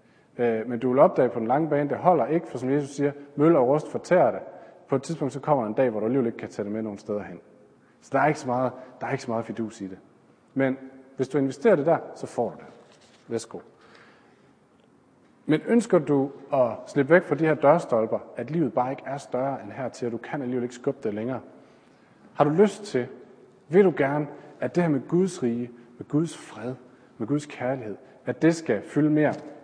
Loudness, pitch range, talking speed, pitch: -25 LUFS, 125-150 Hz, 230 wpm, 135 Hz